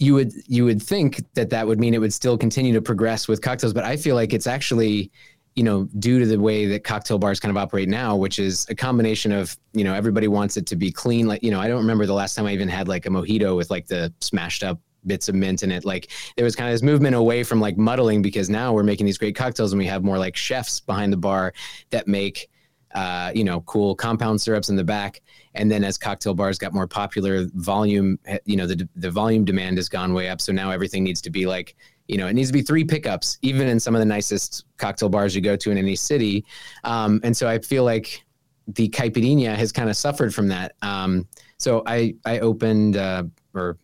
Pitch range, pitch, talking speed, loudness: 100-115 Hz, 105 Hz, 245 wpm, -22 LUFS